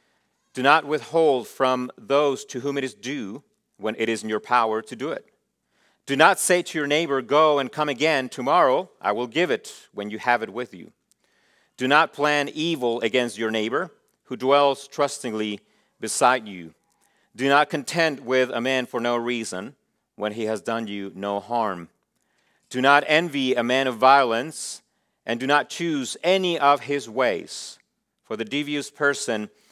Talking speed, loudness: 175 wpm, -23 LUFS